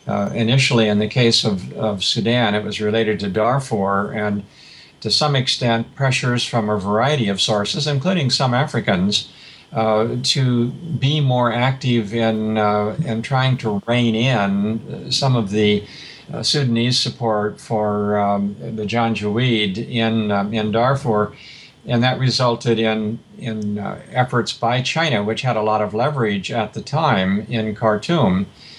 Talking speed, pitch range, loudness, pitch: 150 wpm, 105-130 Hz, -19 LUFS, 115 Hz